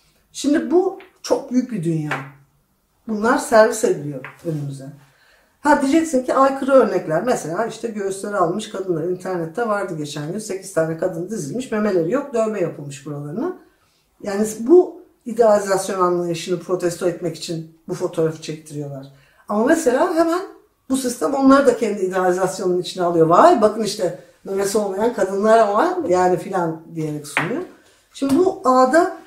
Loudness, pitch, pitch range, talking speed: -19 LUFS, 195 Hz, 170-245 Hz, 140 wpm